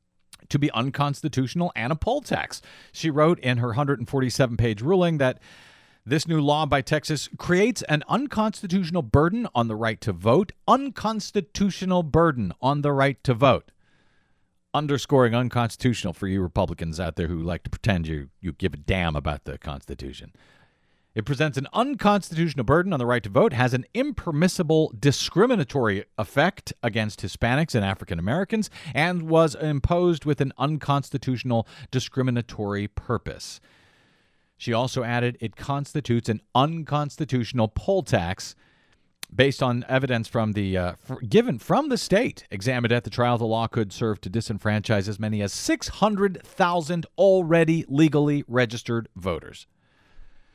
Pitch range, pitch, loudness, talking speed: 110-160 Hz, 130 Hz, -24 LUFS, 140 wpm